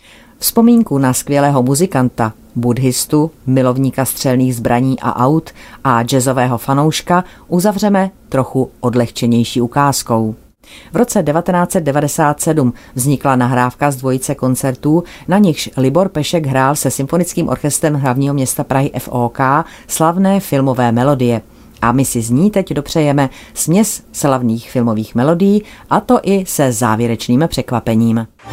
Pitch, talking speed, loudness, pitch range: 135 Hz, 120 wpm, -14 LUFS, 125-160 Hz